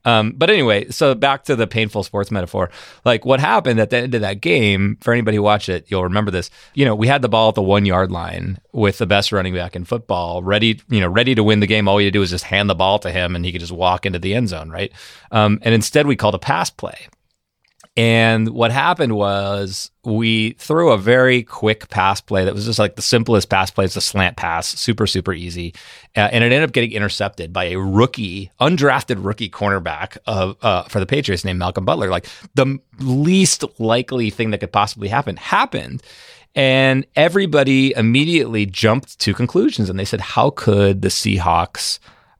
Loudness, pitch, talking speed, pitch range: -17 LUFS, 105 Hz, 210 wpm, 95-120 Hz